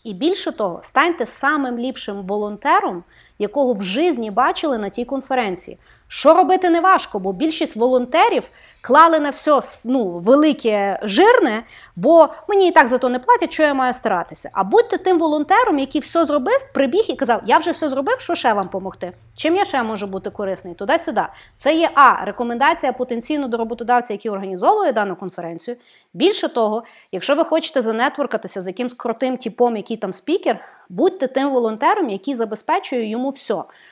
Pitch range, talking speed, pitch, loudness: 220-320 Hz, 170 wpm, 260 Hz, -18 LUFS